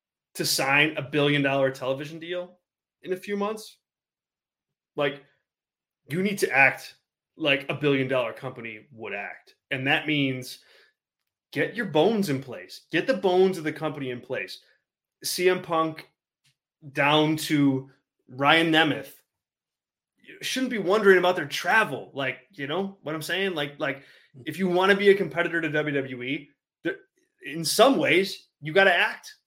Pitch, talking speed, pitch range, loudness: 155 Hz, 155 wpm, 140-185 Hz, -24 LUFS